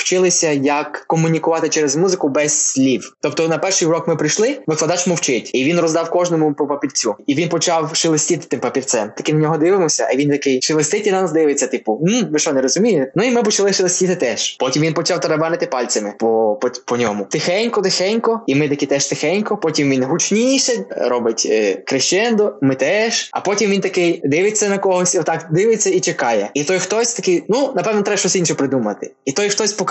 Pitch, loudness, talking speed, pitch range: 165 Hz, -16 LUFS, 190 wpm, 150-190 Hz